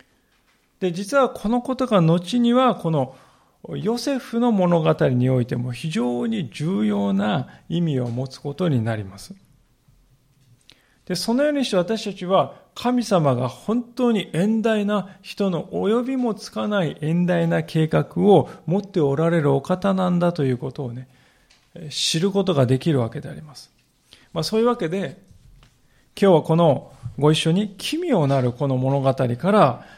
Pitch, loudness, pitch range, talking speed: 170 Hz, -21 LUFS, 135-205 Hz, 280 characters per minute